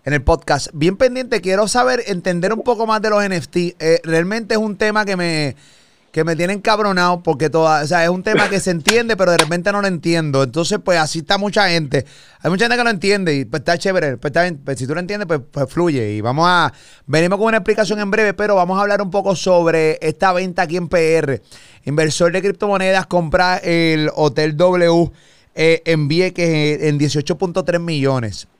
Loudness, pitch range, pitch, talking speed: -16 LUFS, 160-200 Hz, 175 Hz, 210 wpm